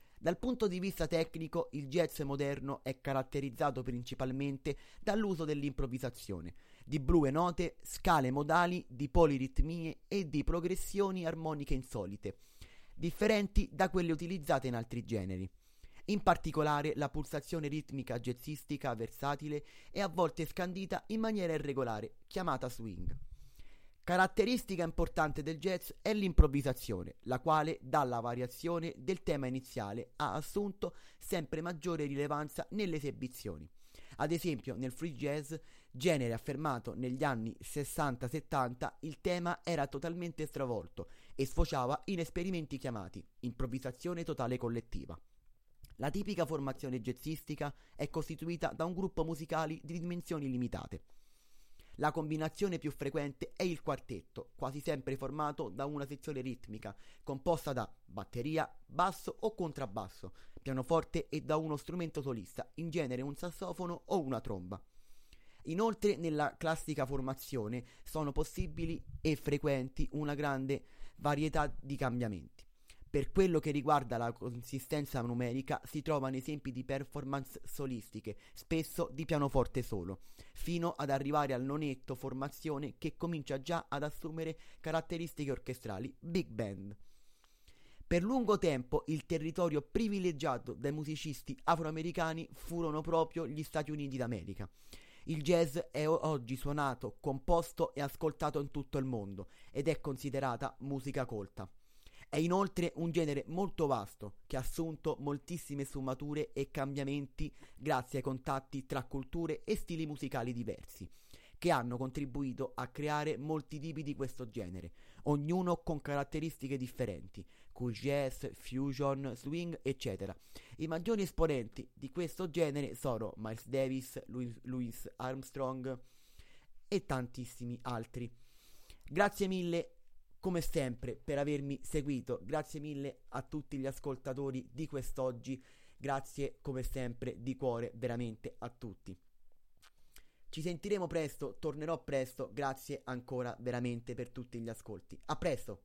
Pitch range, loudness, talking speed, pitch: 125-160 Hz, -38 LUFS, 125 wpm, 140 Hz